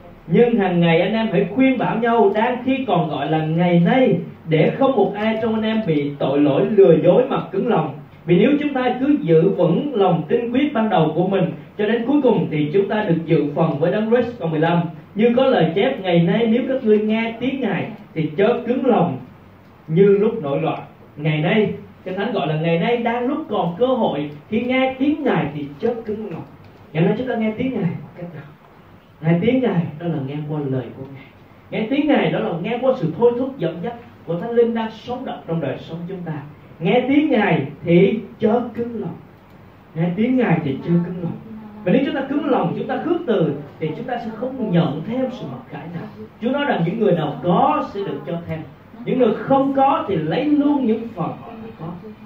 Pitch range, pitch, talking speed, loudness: 165-235 Hz, 200 Hz, 230 wpm, -19 LUFS